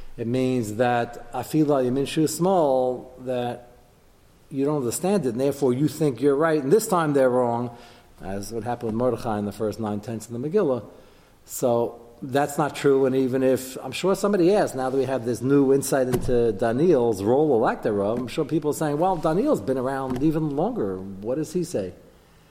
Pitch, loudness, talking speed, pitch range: 130 Hz, -23 LUFS, 210 wpm, 120-145 Hz